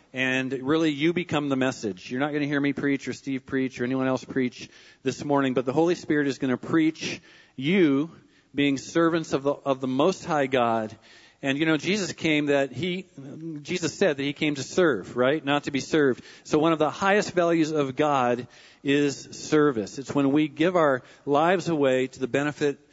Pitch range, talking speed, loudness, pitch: 130-160 Hz, 205 wpm, -25 LUFS, 145 Hz